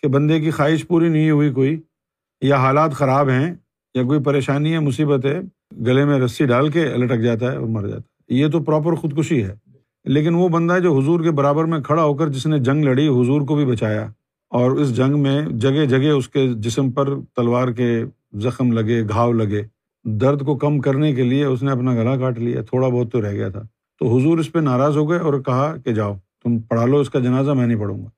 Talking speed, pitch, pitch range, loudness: 235 wpm, 140 Hz, 125-150 Hz, -18 LUFS